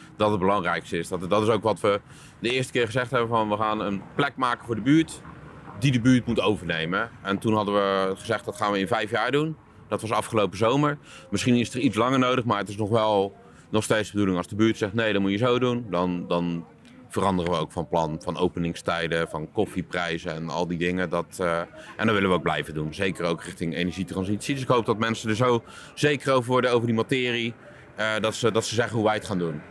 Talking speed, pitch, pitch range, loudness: 245 wpm, 105 Hz, 90-120 Hz, -25 LUFS